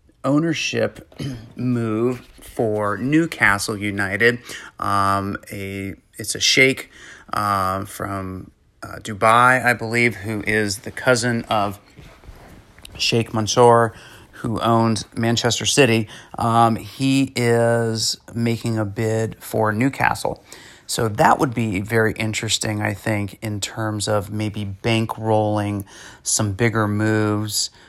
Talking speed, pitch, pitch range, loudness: 110 wpm, 110 Hz, 105-115 Hz, -20 LUFS